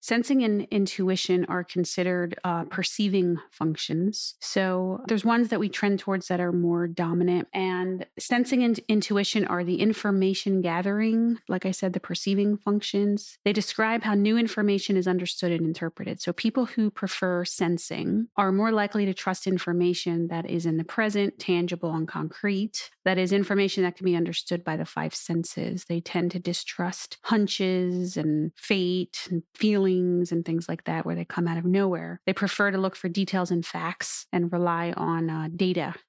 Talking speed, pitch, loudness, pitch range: 175 wpm, 185 Hz, -26 LUFS, 175-205 Hz